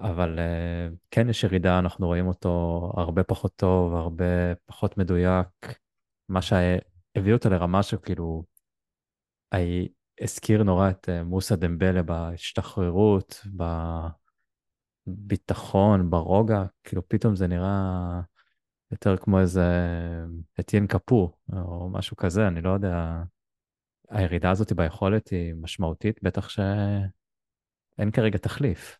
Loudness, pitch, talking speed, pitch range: -26 LUFS, 95 Hz, 105 wpm, 90-105 Hz